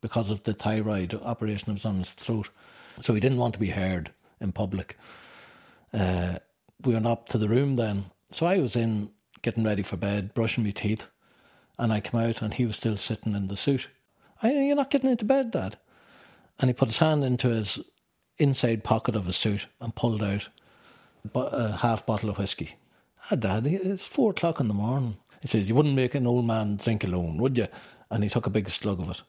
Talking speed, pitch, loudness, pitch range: 215 wpm, 110 Hz, -28 LUFS, 105-125 Hz